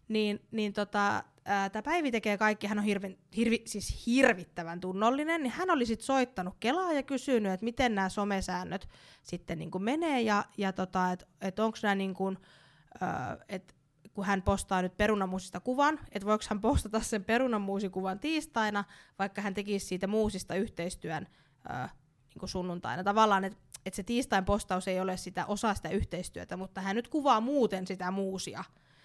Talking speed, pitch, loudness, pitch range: 160 wpm, 200 Hz, -32 LUFS, 185-225 Hz